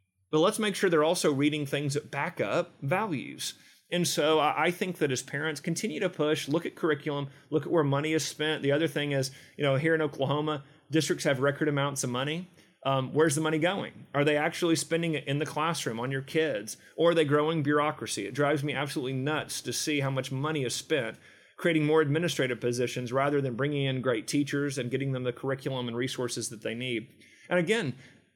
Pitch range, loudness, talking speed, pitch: 135-160 Hz, -29 LUFS, 215 wpm, 145 Hz